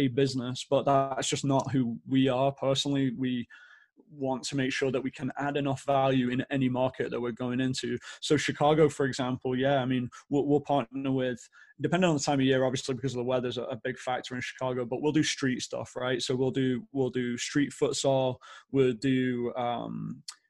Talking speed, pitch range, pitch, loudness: 210 wpm, 125-140 Hz, 130 Hz, -29 LUFS